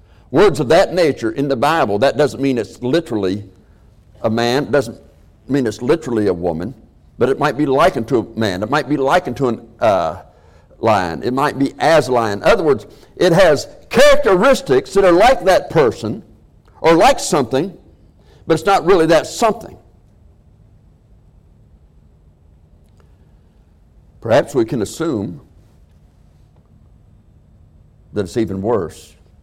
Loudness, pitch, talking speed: -15 LUFS, 105 Hz, 140 wpm